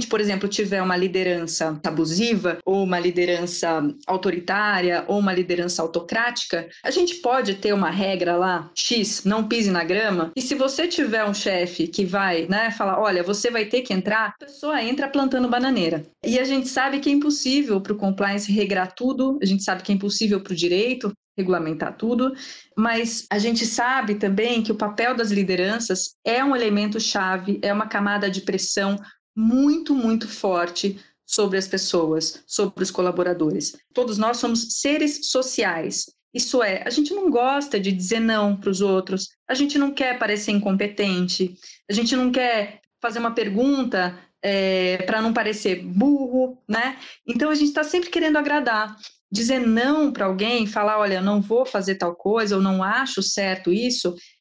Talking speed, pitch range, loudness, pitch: 175 wpm, 190-245 Hz, -22 LUFS, 210 Hz